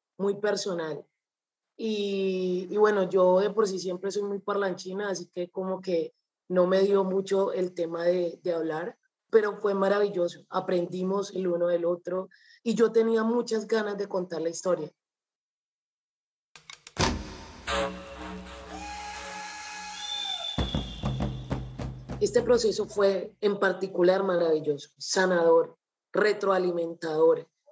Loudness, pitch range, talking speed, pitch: -28 LUFS, 175-210 Hz, 110 wpm, 190 Hz